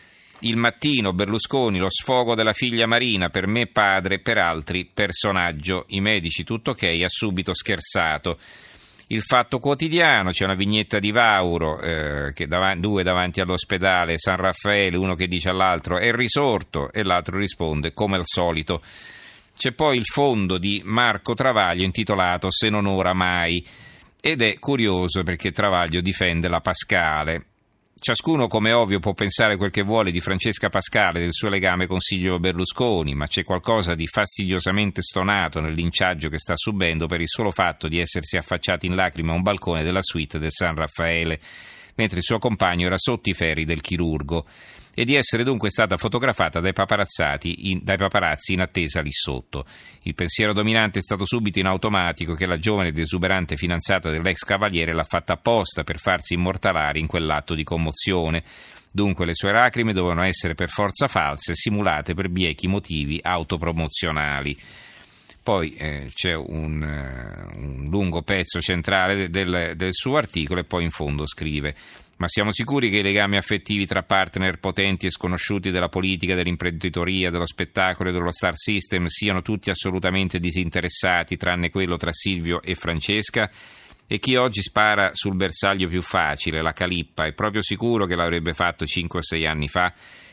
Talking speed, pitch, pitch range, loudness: 165 wpm, 95 Hz, 85-100 Hz, -22 LUFS